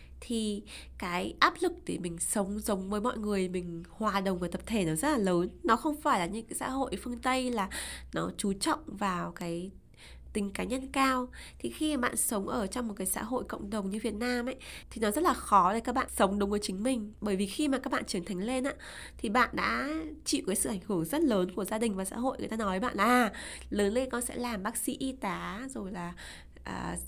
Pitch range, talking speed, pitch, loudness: 195-255 Hz, 255 wpm, 220 Hz, -31 LUFS